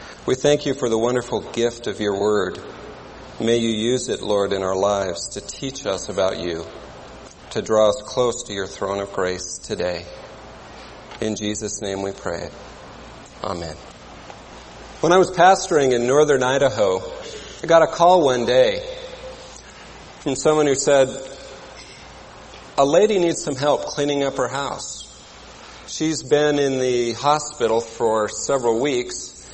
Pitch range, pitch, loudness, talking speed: 105-155 Hz, 125 Hz, -20 LUFS, 150 wpm